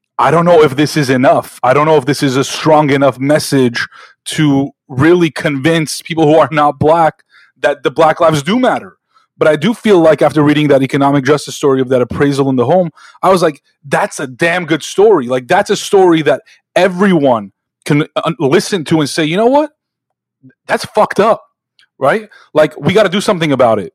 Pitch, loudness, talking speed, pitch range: 155 Hz, -12 LUFS, 205 wpm, 140-180 Hz